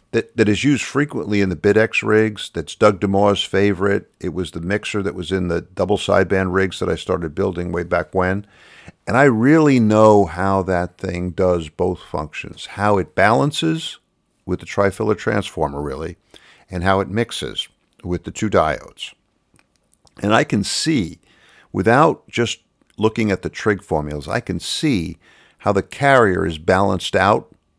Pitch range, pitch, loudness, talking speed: 90-110 Hz, 100 Hz, -18 LUFS, 165 wpm